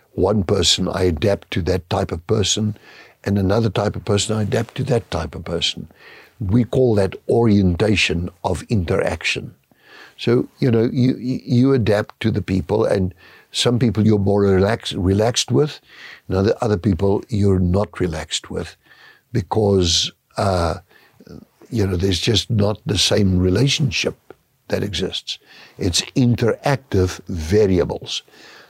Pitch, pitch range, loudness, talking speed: 105 Hz, 95-115 Hz, -19 LUFS, 140 wpm